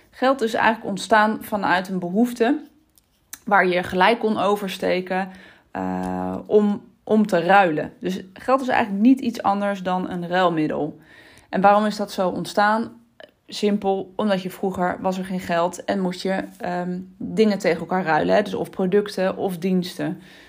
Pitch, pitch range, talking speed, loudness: 195 Hz, 180-215 Hz, 160 wpm, -21 LUFS